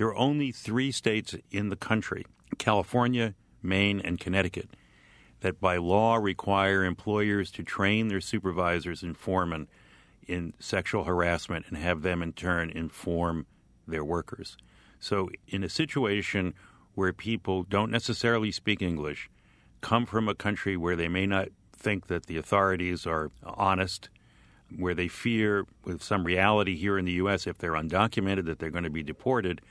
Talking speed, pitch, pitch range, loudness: 155 wpm, 95 Hz, 90-105 Hz, -29 LUFS